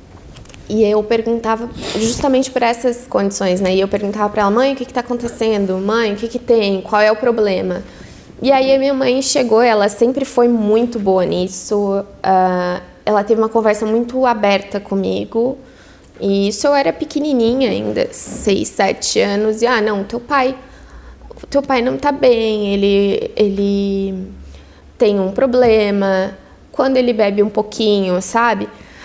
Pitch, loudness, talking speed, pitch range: 220 Hz, -15 LUFS, 160 wpm, 200-245 Hz